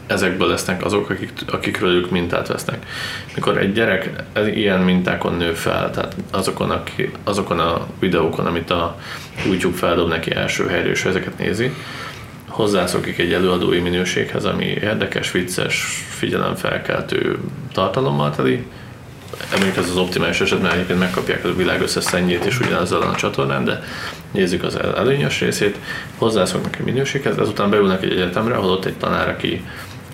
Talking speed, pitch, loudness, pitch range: 150 wpm, 90 Hz, -19 LUFS, 90-115 Hz